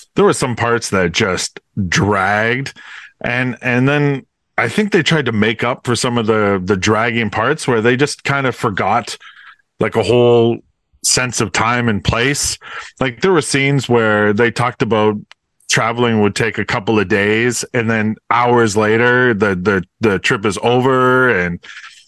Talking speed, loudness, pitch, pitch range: 175 wpm, -15 LUFS, 120 Hz, 110-125 Hz